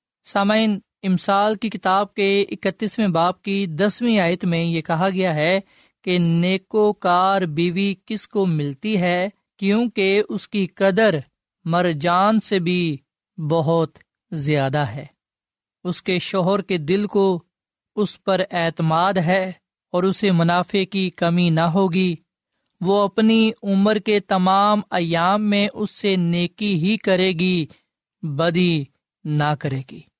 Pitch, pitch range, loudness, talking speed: 185 Hz, 170-200 Hz, -20 LUFS, 135 wpm